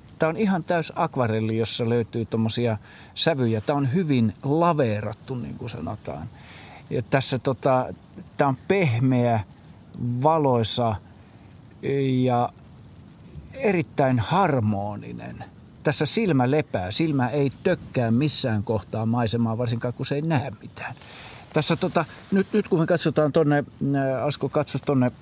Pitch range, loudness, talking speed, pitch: 115-150 Hz, -24 LUFS, 125 wpm, 130 Hz